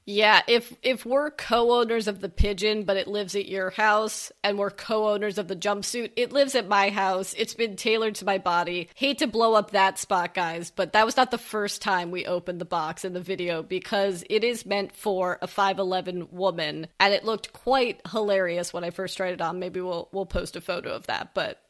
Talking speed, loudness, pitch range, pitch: 220 wpm, -25 LUFS, 185-220 Hz, 200 Hz